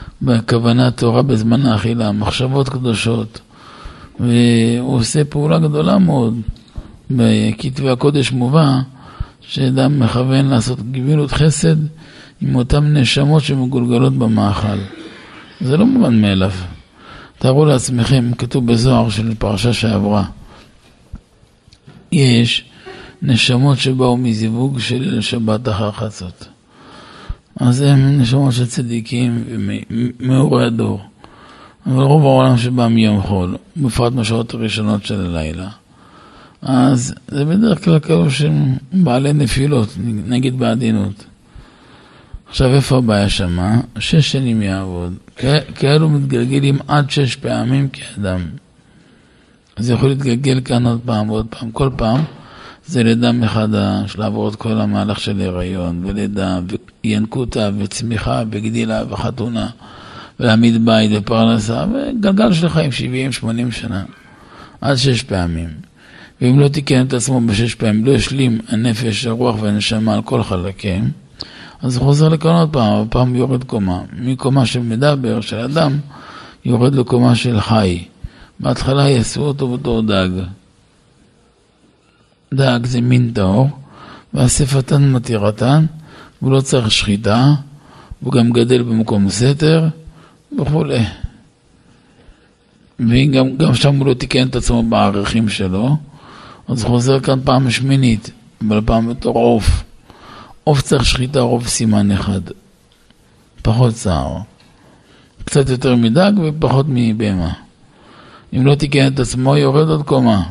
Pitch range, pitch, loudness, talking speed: 110-135 Hz, 120 Hz, -15 LUFS, 115 wpm